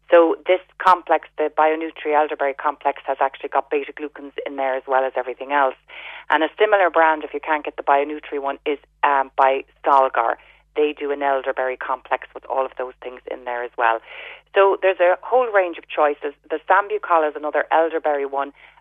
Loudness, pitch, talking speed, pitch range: -20 LUFS, 150 Hz, 195 wpm, 135-160 Hz